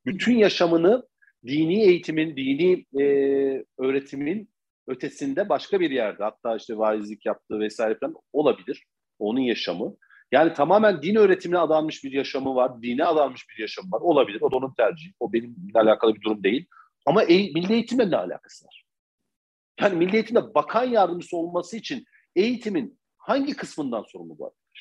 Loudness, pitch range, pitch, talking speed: -23 LUFS, 135-220 Hz, 170 Hz, 150 wpm